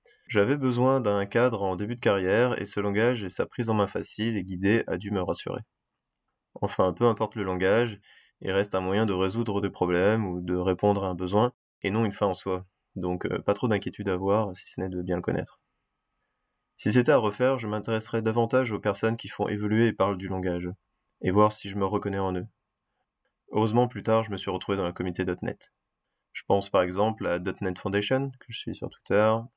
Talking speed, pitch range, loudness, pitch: 220 wpm, 95-115 Hz, -27 LUFS, 100 Hz